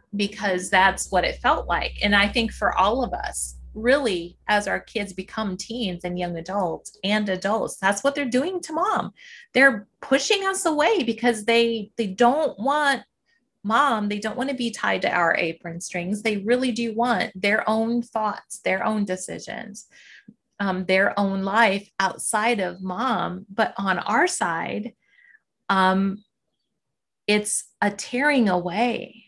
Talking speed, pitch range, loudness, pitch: 155 wpm, 195-240 Hz, -23 LUFS, 215 Hz